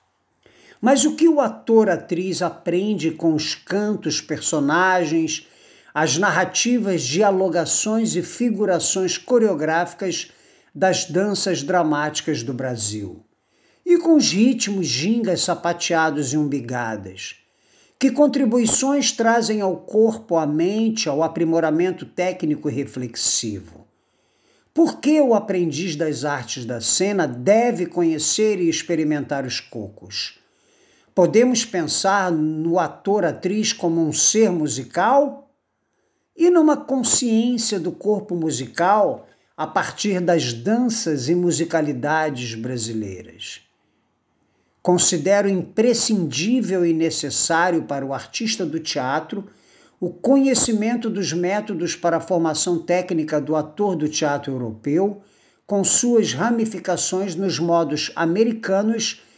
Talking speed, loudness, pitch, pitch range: 105 wpm, -20 LUFS, 180 Hz, 155-215 Hz